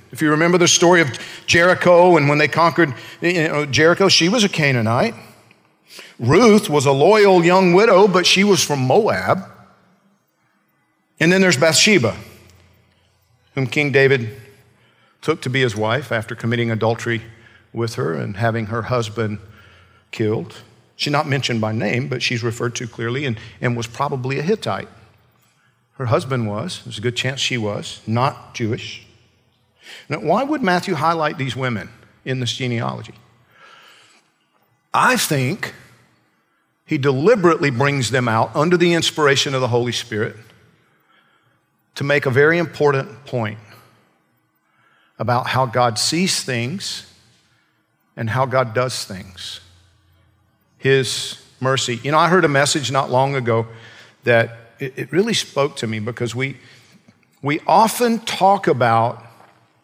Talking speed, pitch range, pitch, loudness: 140 wpm, 115-150 Hz, 125 Hz, -17 LUFS